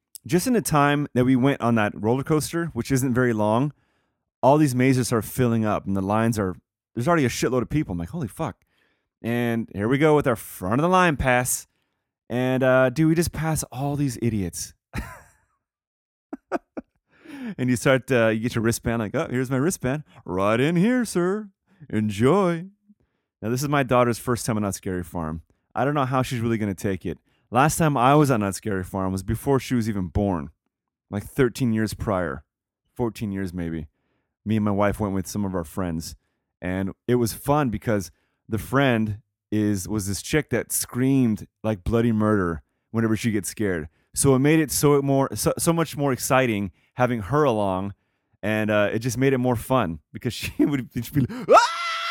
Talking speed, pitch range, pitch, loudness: 200 wpm, 105-140 Hz, 120 Hz, -23 LUFS